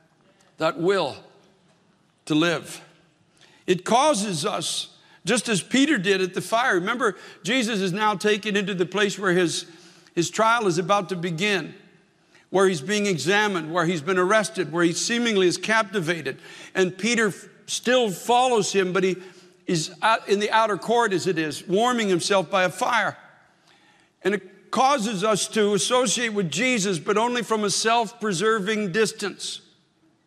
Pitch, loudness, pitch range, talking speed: 195 Hz, -23 LUFS, 180-215 Hz, 155 wpm